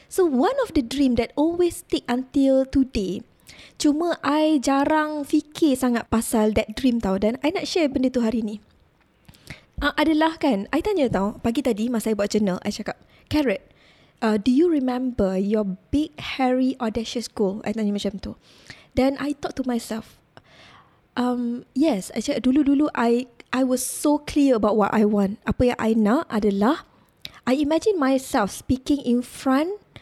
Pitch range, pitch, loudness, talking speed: 220-295 Hz, 255 Hz, -22 LUFS, 170 wpm